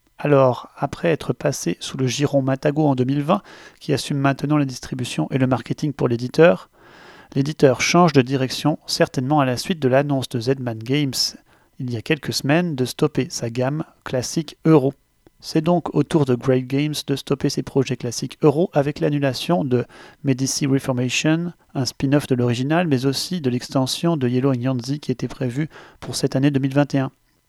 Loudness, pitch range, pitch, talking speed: -21 LUFS, 130-150 Hz, 140 Hz, 175 wpm